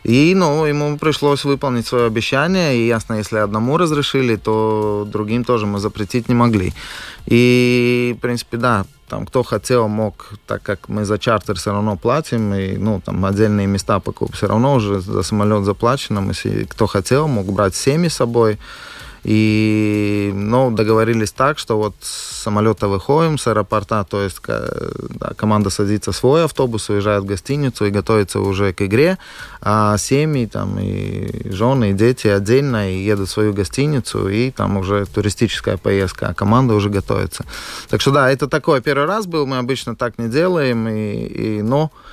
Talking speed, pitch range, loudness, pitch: 170 wpm, 105-125 Hz, -17 LUFS, 110 Hz